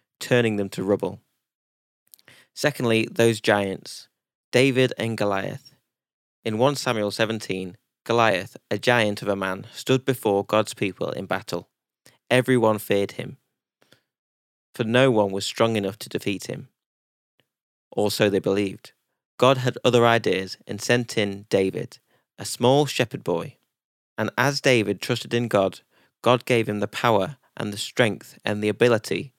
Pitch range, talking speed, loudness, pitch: 100-125 Hz, 145 wpm, -23 LUFS, 110 Hz